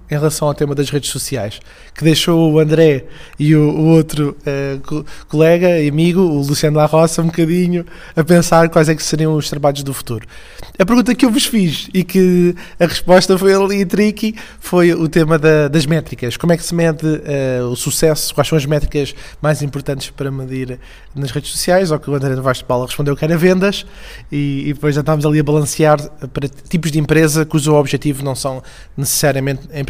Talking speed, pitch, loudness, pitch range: 205 wpm, 155 Hz, -14 LUFS, 140-165 Hz